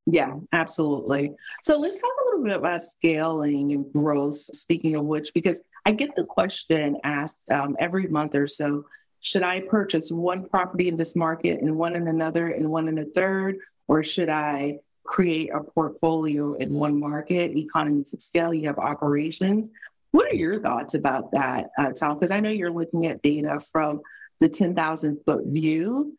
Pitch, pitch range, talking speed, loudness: 160 Hz, 150-185 Hz, 180 wpm, -24 LUFS